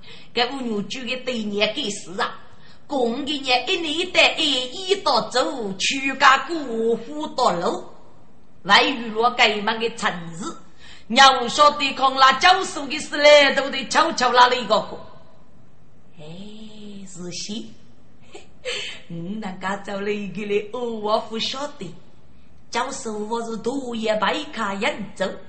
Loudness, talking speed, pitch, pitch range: -20 LUFS, 190 characters per minute, 235 Hz, 210-270 Hz